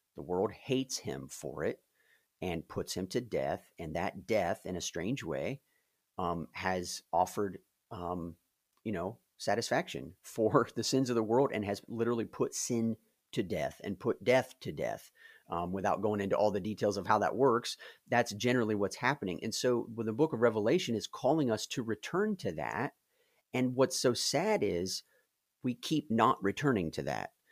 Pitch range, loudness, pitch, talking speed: 100-125 Hz, -33 LUFS, 115 Hz, 185 wpm